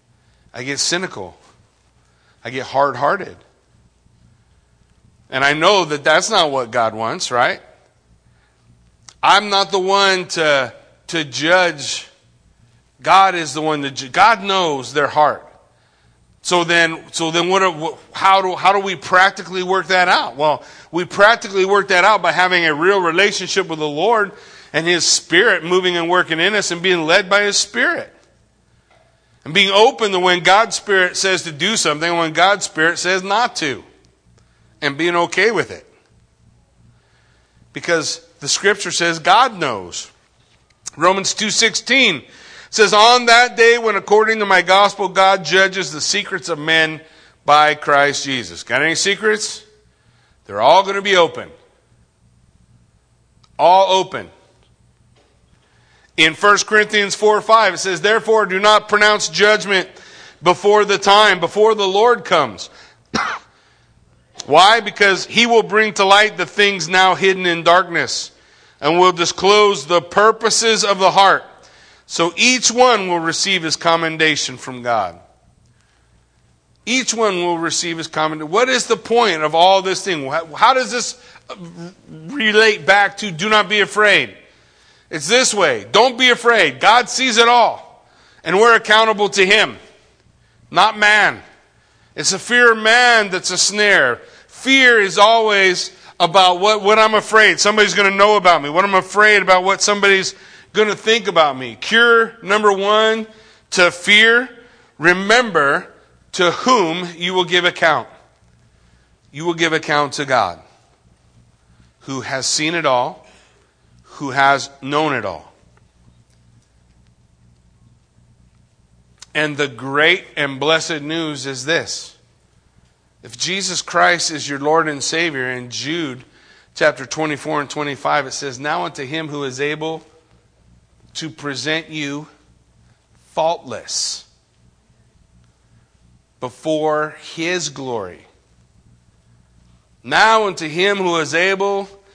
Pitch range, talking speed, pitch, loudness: 150-205 Hz, 140 wpm, 175 Hz, -14 LUFS